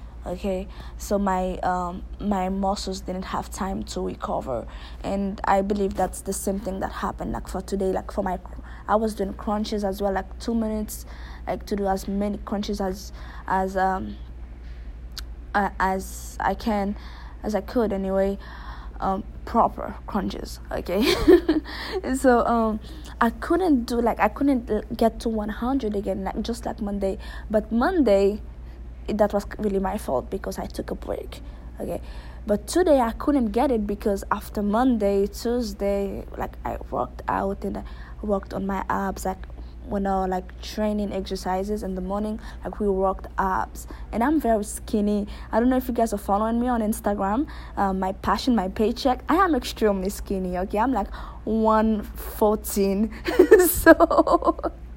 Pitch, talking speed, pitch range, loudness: 205 Hz, 165 wpm, 190-230 Hz, -24 LUFS